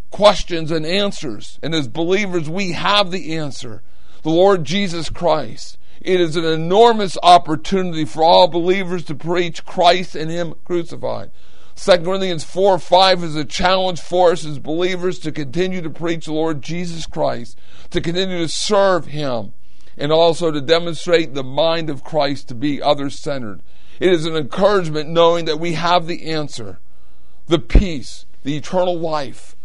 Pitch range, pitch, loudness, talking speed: 150-180 Hz, 165 Hz, -18 LUFS, 160 wpm